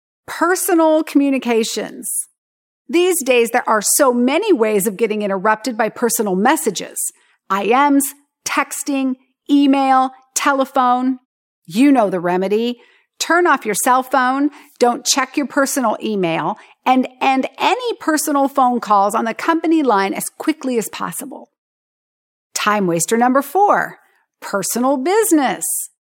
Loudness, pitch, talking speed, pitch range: -16 LUFS, 260 Hz, 120 wpm, 225-290 Hz